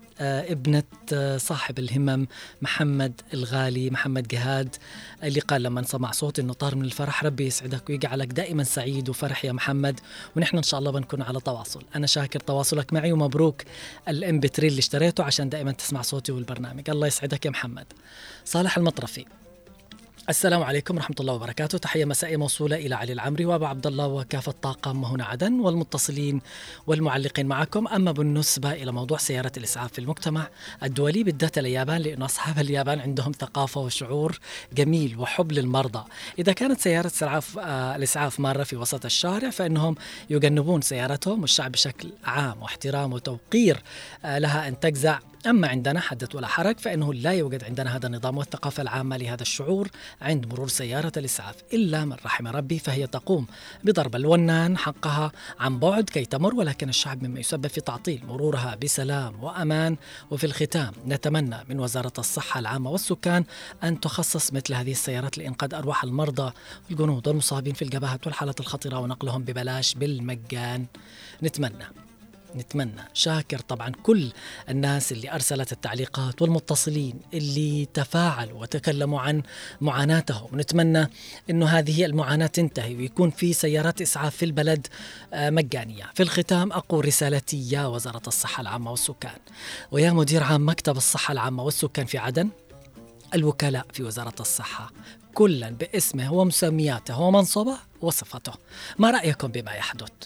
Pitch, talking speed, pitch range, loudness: 145 Hz, 140 wpm, 130-160 Hz, -25 LUFS